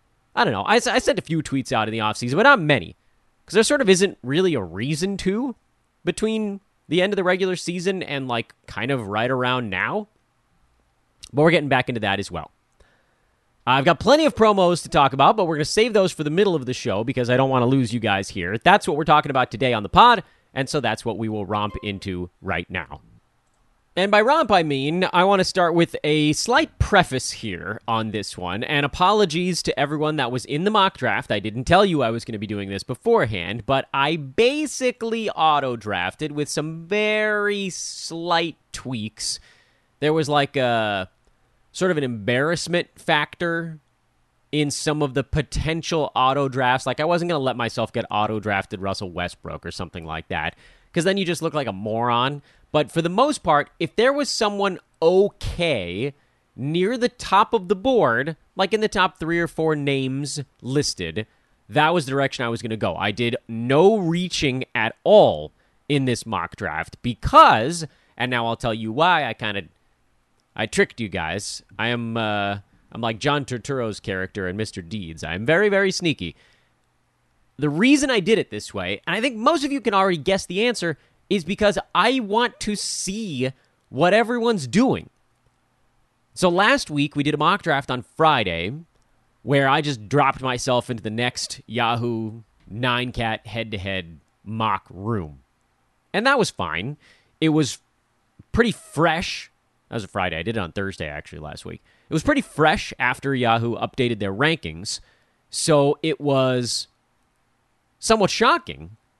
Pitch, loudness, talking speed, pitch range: 135 Hz, -21 LUFS, 190 wpm, 110-175 Hz